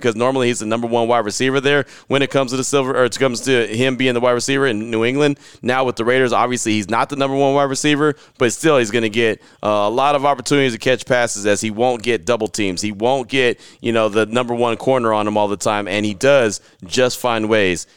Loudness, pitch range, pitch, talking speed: -17 LUFS, 110-135 Hz, 125 Hz, 255 wpm